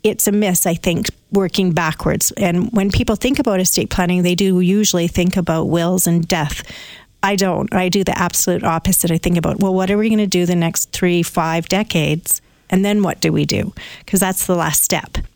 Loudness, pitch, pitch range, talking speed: -16 LUFS, 185 Hz, 175-195 Hz, 215 wpm